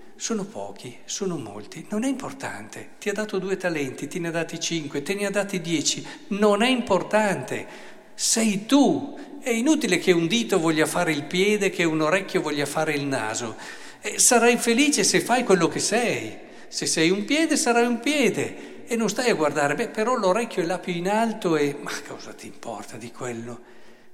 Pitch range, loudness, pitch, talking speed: 155-225 Hz, -23 LUFS, 185 Hz, 195 wpm